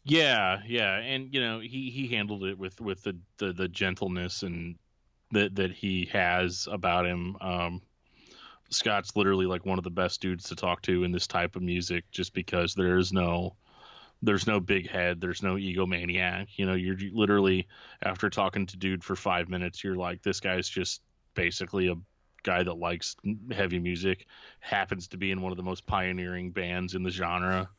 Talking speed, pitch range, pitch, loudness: 190 wpm, 90-100 Hz, 95 Hz, -30 LUFS